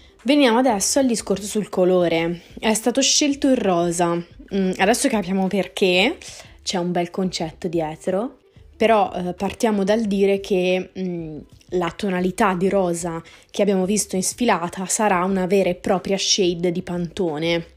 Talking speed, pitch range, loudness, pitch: 140 wpm, 175-210 Hz, -20 LUFS, 190 Hz